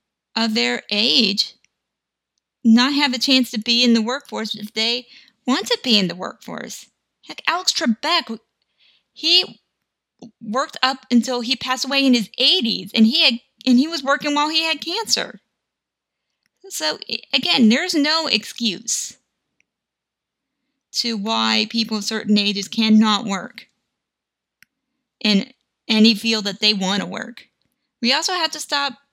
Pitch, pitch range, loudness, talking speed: 240 Hz, 220-275 Hz, -18 LUFS, 145 wpm